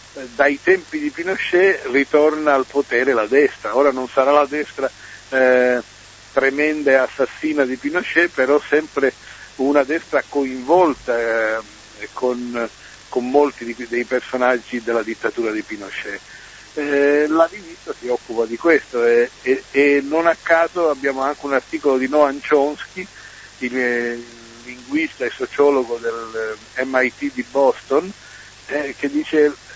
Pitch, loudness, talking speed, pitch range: 140 Hz, -18 LUFS, 140 wpm, 125-160 Hz